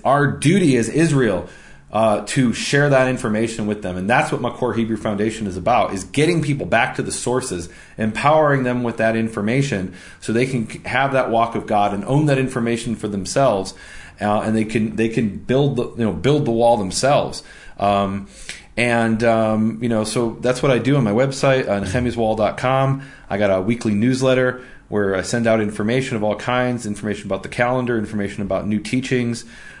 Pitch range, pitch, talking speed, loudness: 105-130 Hz, 115 Hz, 195 wpm, -19 LUFS